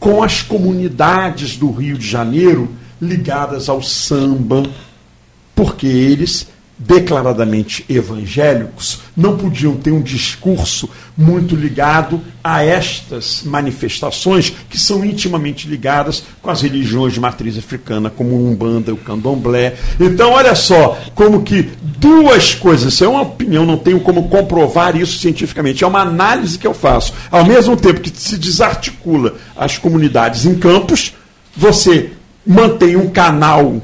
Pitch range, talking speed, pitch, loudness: 130-180 Hz, 135 wpm, 155 Hz, -12 LUFS